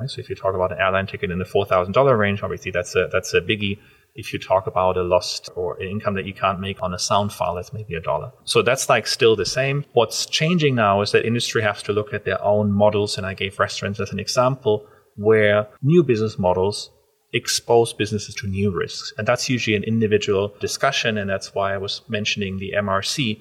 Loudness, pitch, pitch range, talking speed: -21 LUFS, 105 Hz, 100-120 Hz, 225 wpm